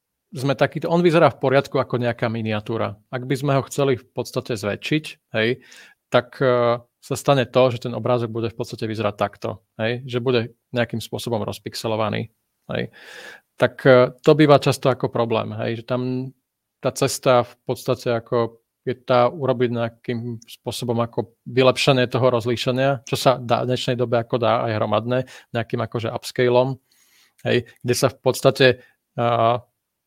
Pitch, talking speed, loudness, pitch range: 125 Hz, 160 wpm, -21 LUFS, 115-130 Hz